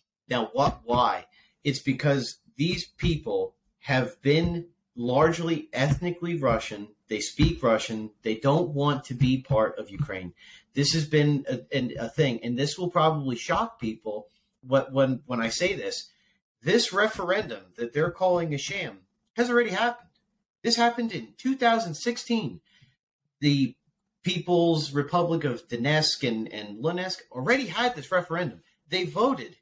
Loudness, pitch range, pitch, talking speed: -27 LUFS, 135-185 Hz, 155 Hz, 140 wpm